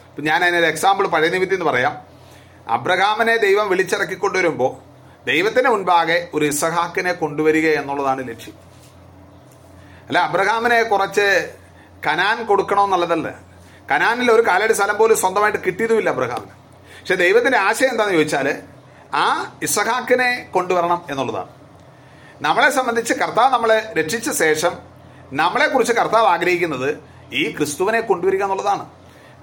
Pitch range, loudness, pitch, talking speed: 150-220 Hz, -18 LUFS, 180 Hz, 110 wpm